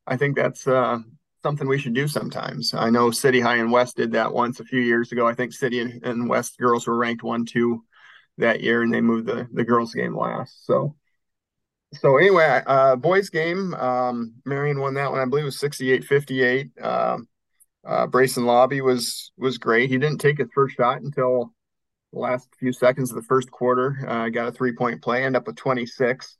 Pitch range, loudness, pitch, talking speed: 120-130 Hz, -22 LUFS, 125 Hz, 200 wpm